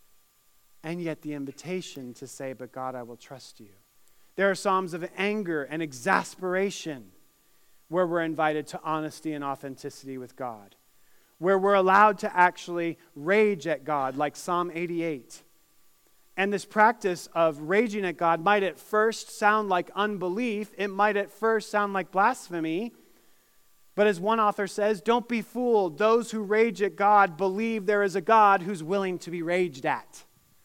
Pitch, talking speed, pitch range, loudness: 185 Hz, 165 wpm, 155-205 Hz, -26 LUFS